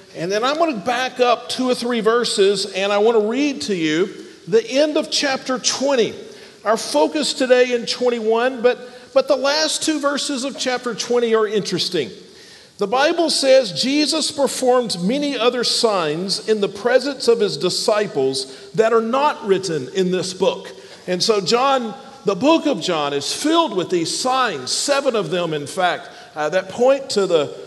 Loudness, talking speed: -18 LUFS, 180 wpm